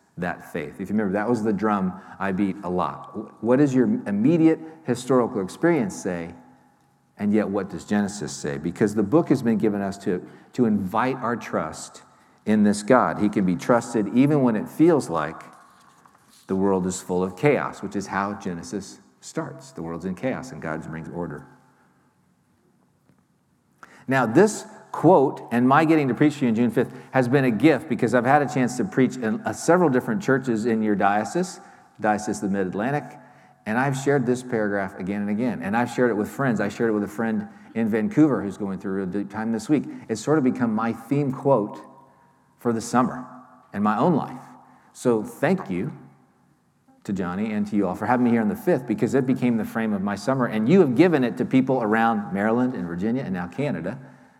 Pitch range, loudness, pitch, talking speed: 100-130 Hz, -23 LUFS, 115 Hz, 205 wpm